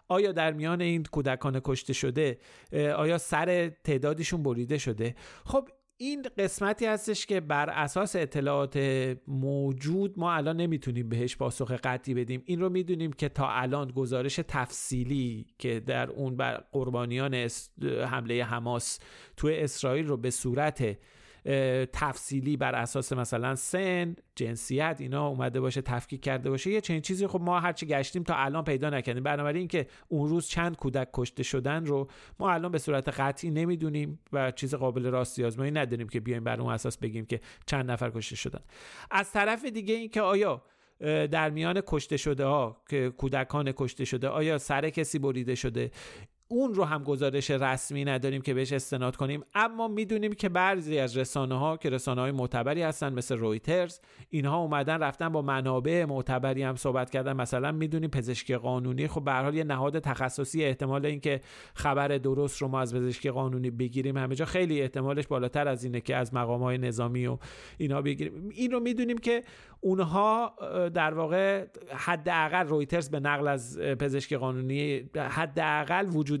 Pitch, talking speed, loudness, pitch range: 140 Hz, 160 wpm, -30 LUFS, 130-160 Hz